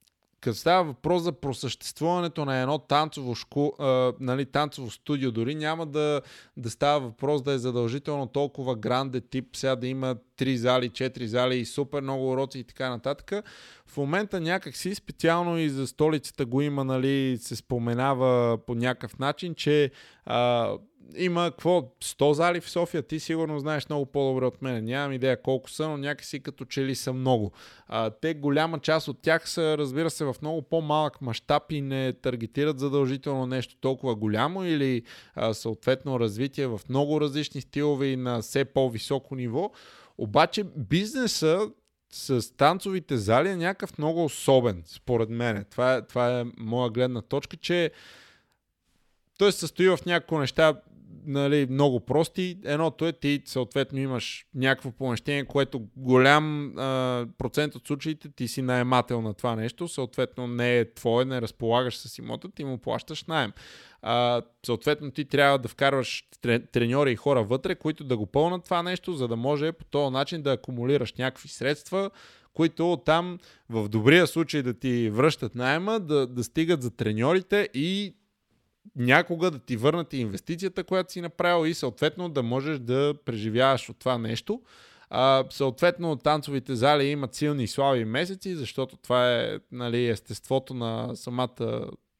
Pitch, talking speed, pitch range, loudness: 135 Hz, 155 wpm, 125-155 Hz, -27 LUFS